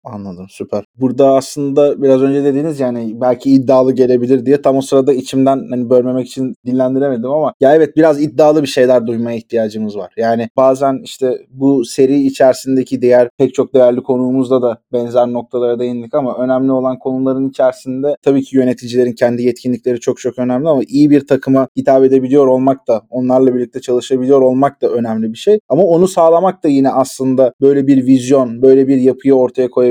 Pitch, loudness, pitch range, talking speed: 130 Hz, -13 LUFS, 125-135 Hz, 175 wpm